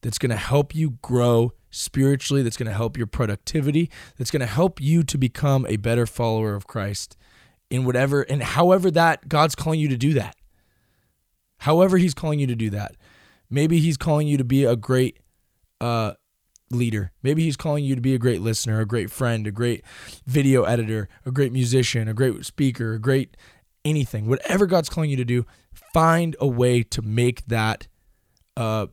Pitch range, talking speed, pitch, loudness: 115-145 Hz, 190 wpm, 125 Hz, -22 LUFS